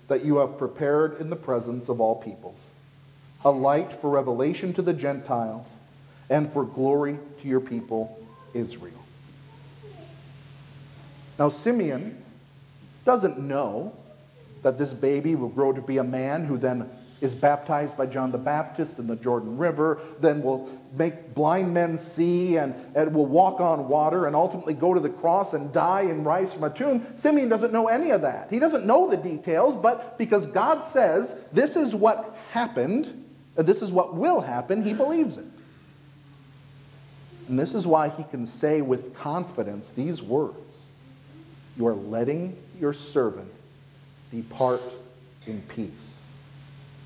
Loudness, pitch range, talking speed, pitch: -25 LUFS, 135-170 Hz, 155 wpm, 145 Hz